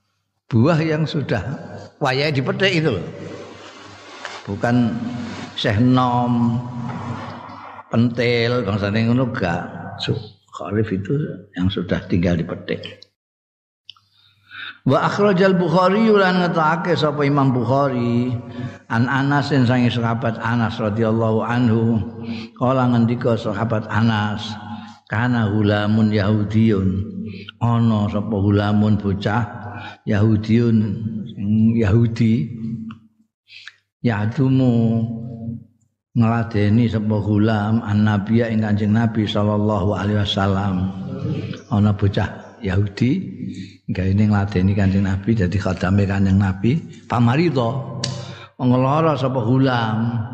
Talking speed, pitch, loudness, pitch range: 85 wpm, 115 Hz, -19 LUFS, 105-120 Hz